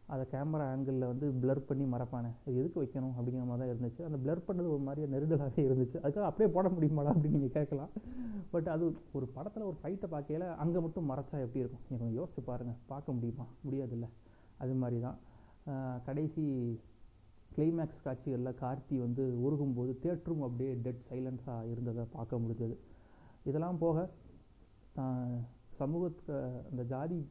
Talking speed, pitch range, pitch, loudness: 150 wpm, 125-155 Hz, 135 Hz, -37 LUFS